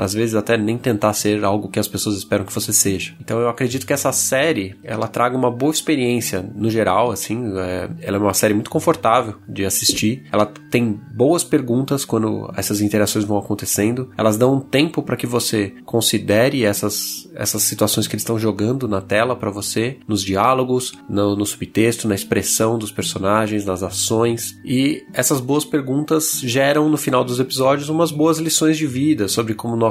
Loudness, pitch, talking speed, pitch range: -18 LUFS, 110 Hz, 185 wpm, 105-130 Hz